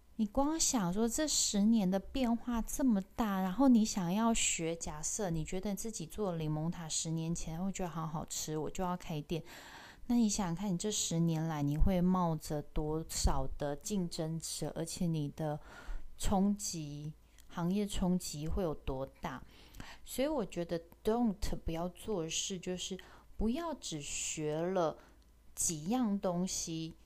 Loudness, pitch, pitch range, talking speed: -35 LUFS, 180 Hz, 160-210 Hz, 225 characters per minute